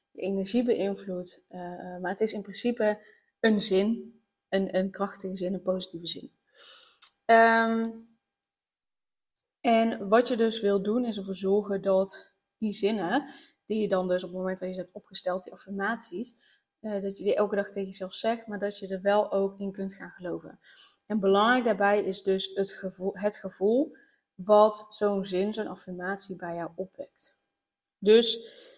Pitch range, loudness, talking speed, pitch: 190-225 Hz, -27 LUFS, 170 wpm, 200 Hz